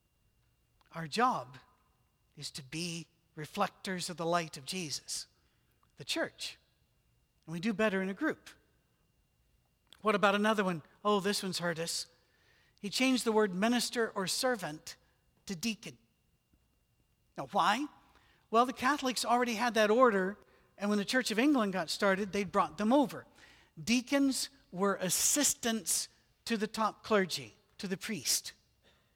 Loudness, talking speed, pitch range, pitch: -32 LUFS, 140 wpm, 170-230 Hz, 200 Hz